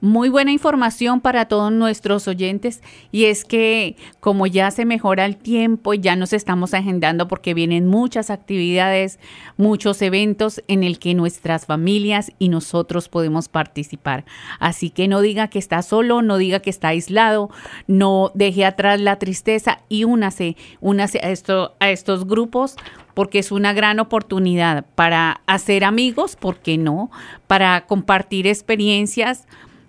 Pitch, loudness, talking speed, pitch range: 195 Hz, -18 LUFS, 150 wpm, 180-215 Hz